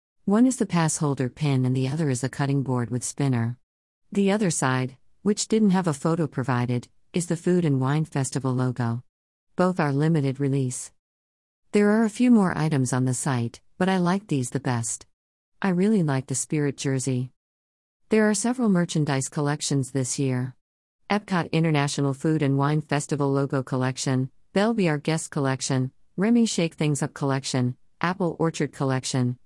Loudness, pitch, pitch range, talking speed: -24 LUFS, 140 Hz, 130-165 Hz, 165 wpm